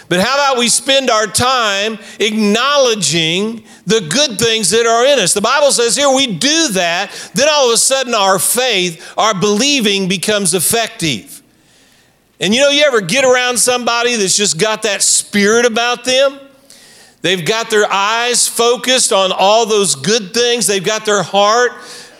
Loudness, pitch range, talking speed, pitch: -12 LUFS, 205-250 Hz, 170 wpm, 225 Hz